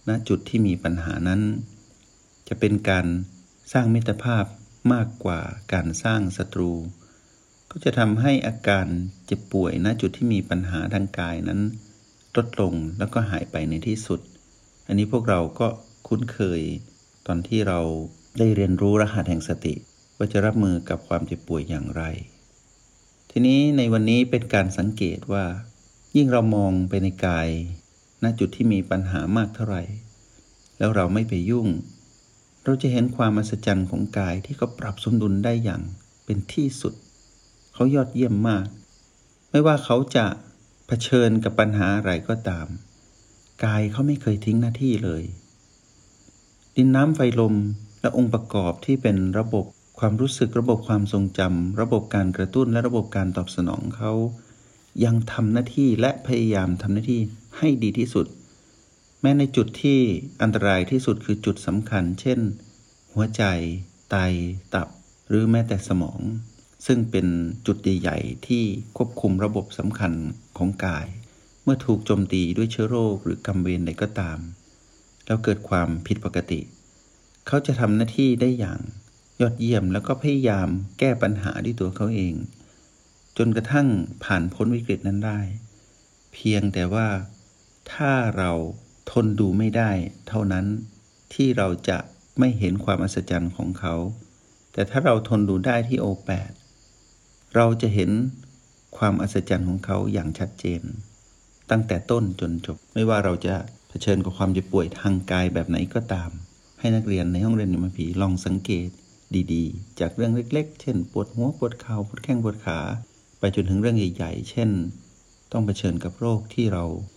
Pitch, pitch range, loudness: 105 Hz, 95-115 Hz, -24 LUFS